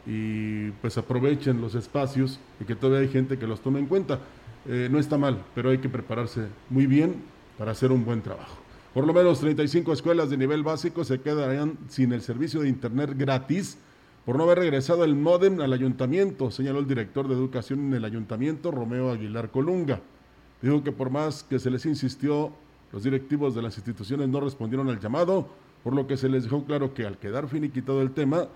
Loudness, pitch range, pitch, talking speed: -26 LUFS, 120-145 Hz, 135 Hz, 200 wpm